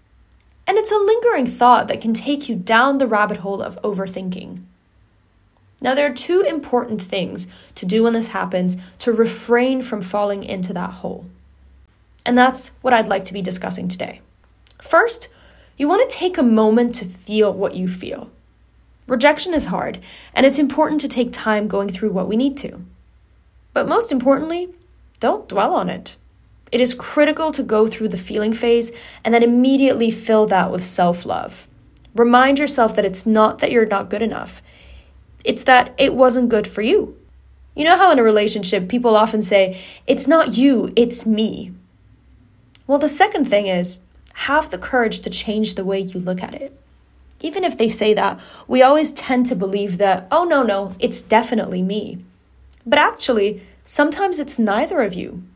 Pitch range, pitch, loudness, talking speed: 195-270 Hz, 225 Hz, -17 LUFS, 175 wpm